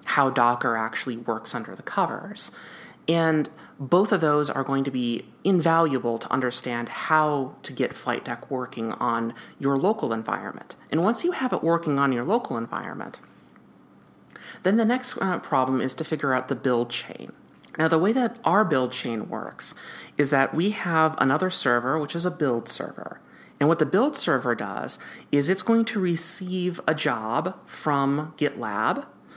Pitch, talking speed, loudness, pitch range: 150 Hz, 170 wpm, -25 LUFS, 130-180 Hz